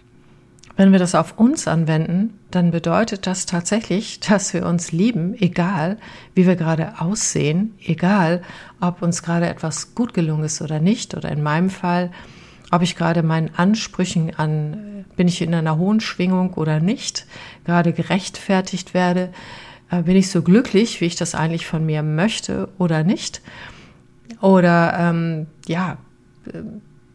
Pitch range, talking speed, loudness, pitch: 165-190 Hz, 145 wpm, -19 LUFS, 175 Hz